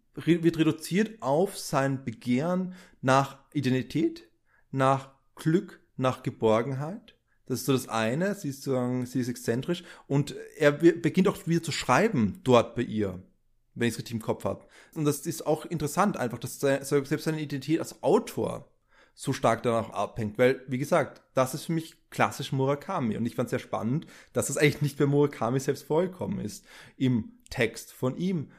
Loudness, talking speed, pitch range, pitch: -28 LUFS, 175 wpm, 125-160 Hz, 140 Hz